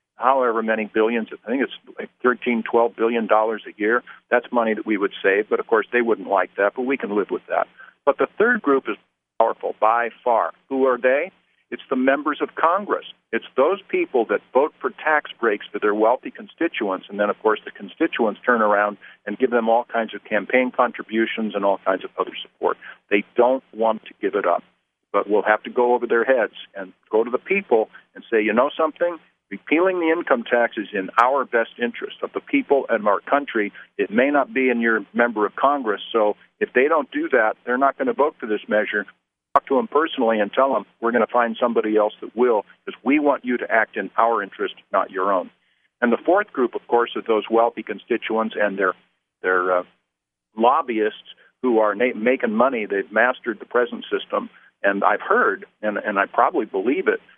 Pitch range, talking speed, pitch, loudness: 110-150 Hz, 215 wpm, 120 Hz, -21 LUFS